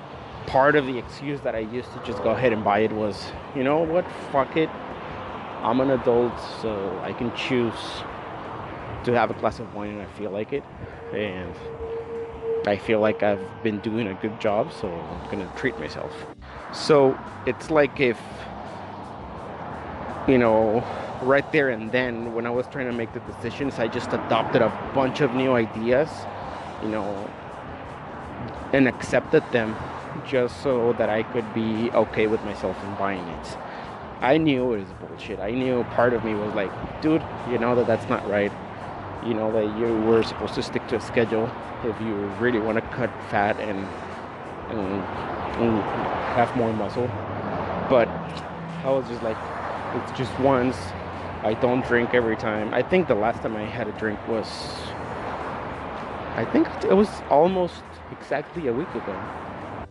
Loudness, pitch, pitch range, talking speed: -25 LUFS, 115 Hz, 105-125 Hz, 170 wpm